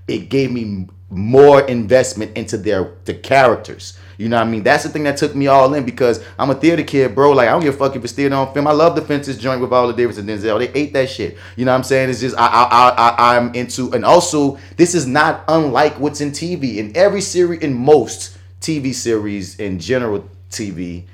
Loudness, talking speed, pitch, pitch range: -15 LUFS, 240 wpm, 130 Hz, 110-145 Hz